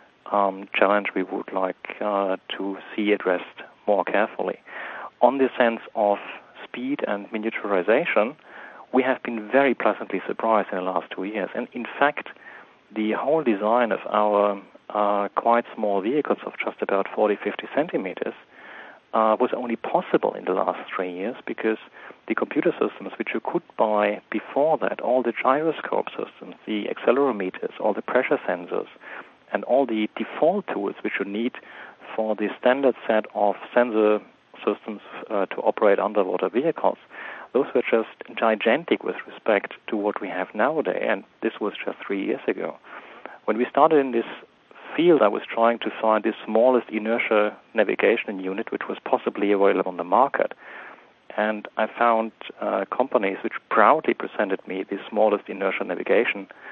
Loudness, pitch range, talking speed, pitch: -24 LUFS, 100-115 Hz, 160 wpm, 110 Hz